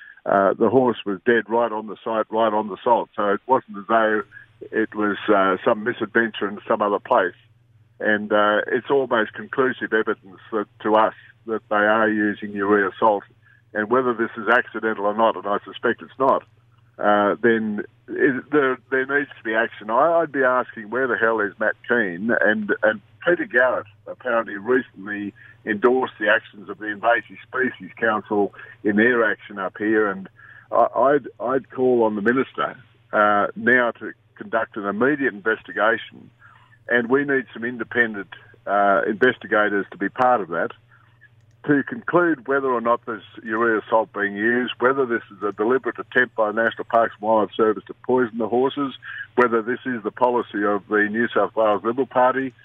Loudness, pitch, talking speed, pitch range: -21 LUFS, 115 Hz, 180 wpm, 105-120 Hz